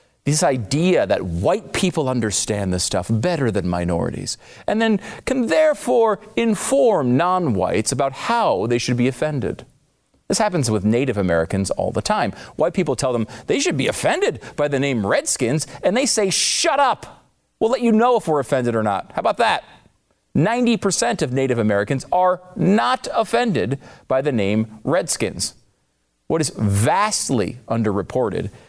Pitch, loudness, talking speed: 140 Hz, -20 LUFS, 160 wpm